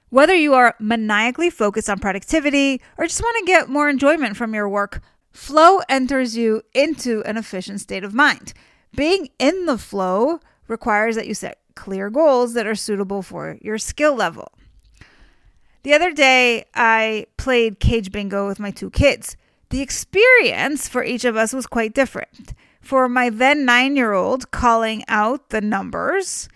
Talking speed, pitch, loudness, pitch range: 165 wpm, 245 Hz, -18 LUFS, 215-285 Hz